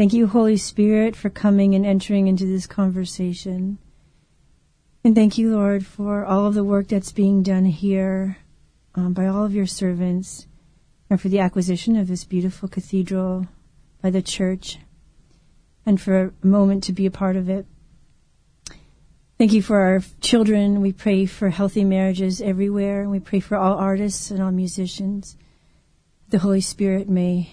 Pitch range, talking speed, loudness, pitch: 185-200 Hz, 165 wpm, -20 LUFS, 195 Hz